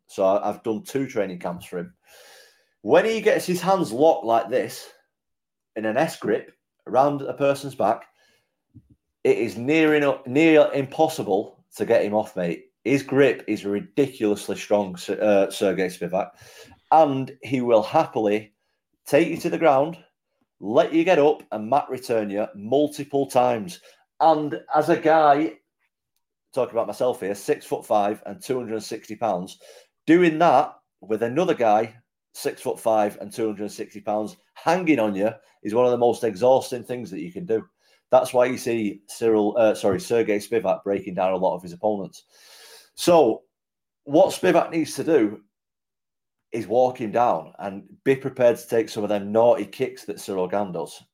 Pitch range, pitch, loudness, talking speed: 105-145 Hz, 125 Hz, -22 LUFS, 170 wpm